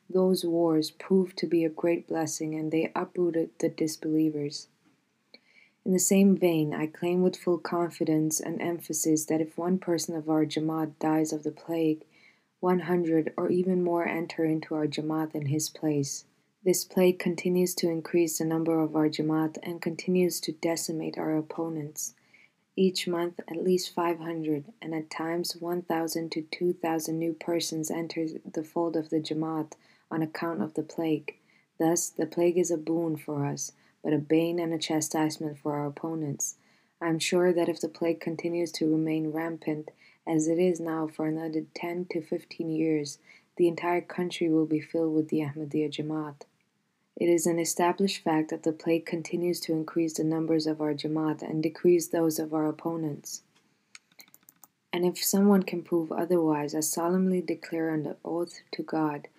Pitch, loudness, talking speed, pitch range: 165 Hz, -29 LUFS, 175 wpm, 155-175 Hz